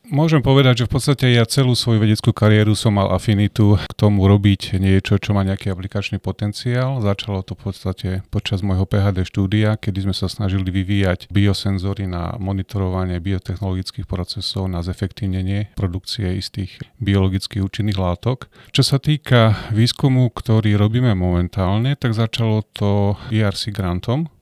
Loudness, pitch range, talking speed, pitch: -19 LUFS, 95-115 Hz, 145 wpm, 100 Hz